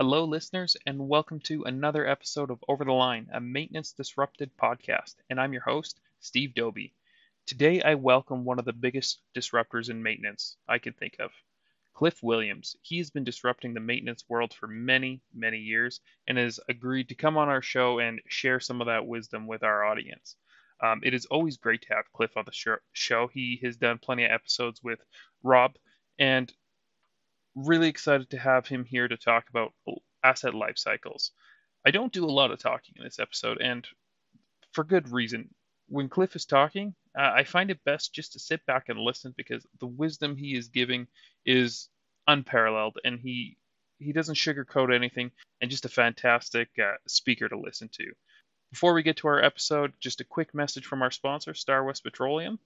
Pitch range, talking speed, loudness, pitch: 120-145 Hz, 185 wpm, -28 LUFS, 130 Hz